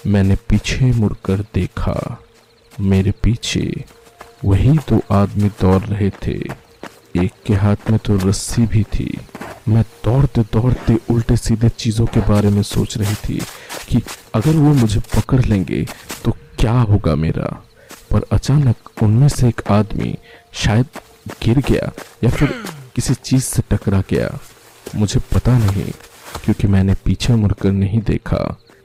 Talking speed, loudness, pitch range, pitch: 140 wpm, -17 LUFS, 100-120 Hz, 110 Hz